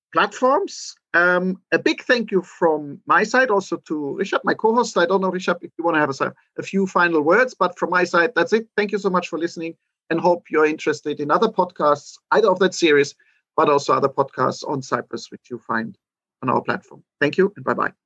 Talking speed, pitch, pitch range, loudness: 230 wpm, 175 Hz, 155-195 Hz, -20 LUFS